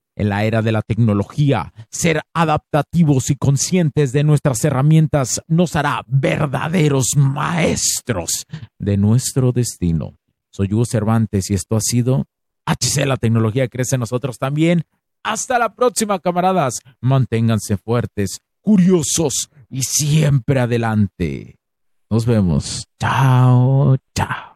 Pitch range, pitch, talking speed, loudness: 115-150 Hz, 135 Hz, 115 wpm, -17 LUFS